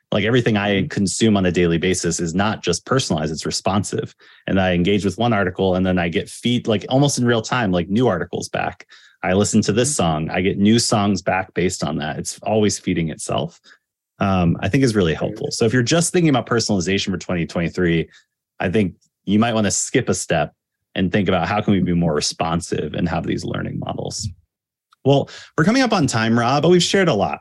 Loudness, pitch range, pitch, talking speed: -19 LUFS, 95-120 Hz, 105 Hz, 220 wpm